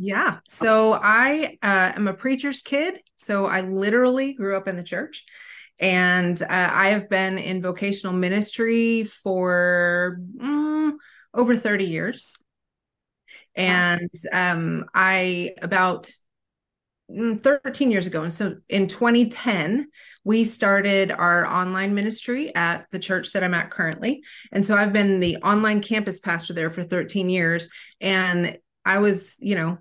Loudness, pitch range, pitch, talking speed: -22 LUFS, 180-225 Hz, 195 Hz, 140 wpm